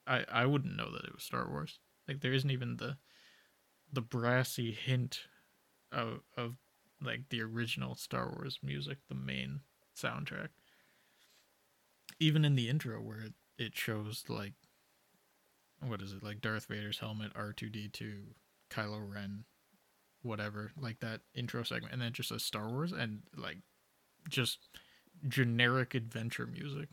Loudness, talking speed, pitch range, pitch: -38 LUFS, 145 wpm, 105-130 Hz, 115 Hz